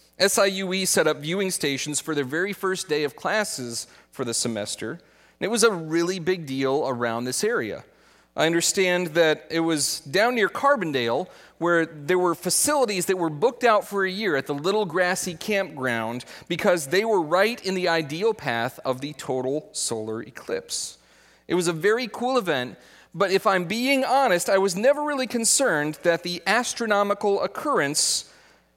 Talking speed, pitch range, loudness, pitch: 170 wpm, 150-205 Hz, -23 LUFS, 180 Hz